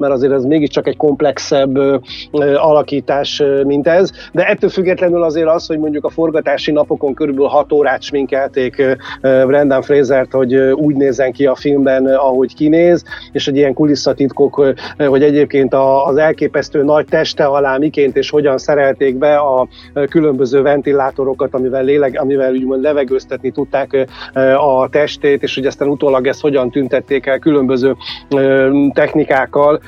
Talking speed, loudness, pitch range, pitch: 160 wpm, -13 LUFS, 135-150 Hz, 140 Hz